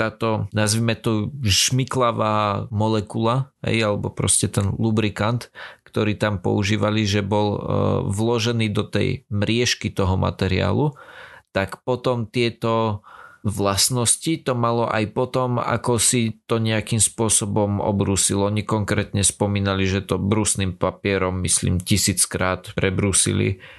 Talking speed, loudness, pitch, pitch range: 115 wpm, -21 LUFS, 105 Hz, 100-115 Hz